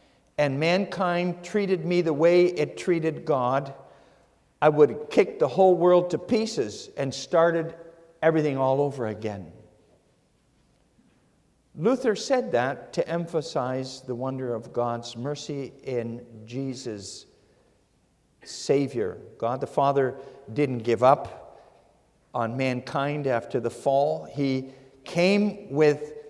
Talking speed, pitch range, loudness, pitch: 115 wpm, 130-175 Hz, -25 LUFS, 145 Hz